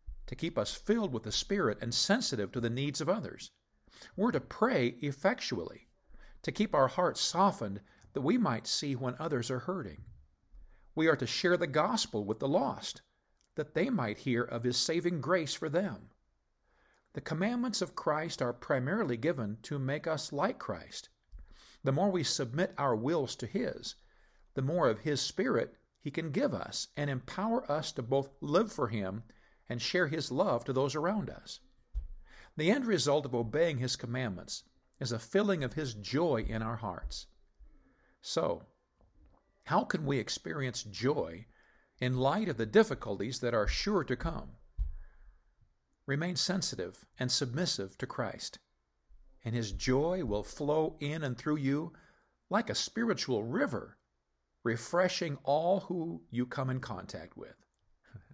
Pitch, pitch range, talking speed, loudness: 135 Hz, 115-165 Hz, 160 wpm, -33 LUFS